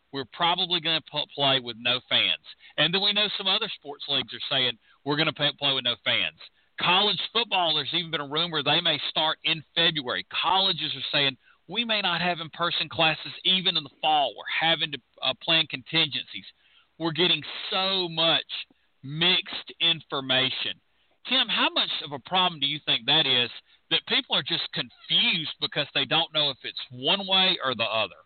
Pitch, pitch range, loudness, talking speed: 160 Hz, 140-180 Hz, -24 LUFS, 190 wpm